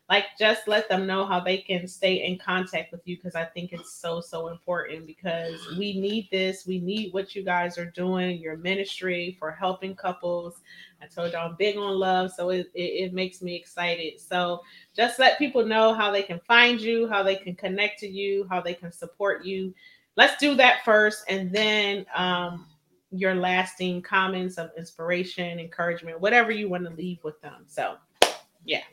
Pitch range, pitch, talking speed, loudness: 175-200 Hz, 185 Hz, 195 wpm, -25 LUFS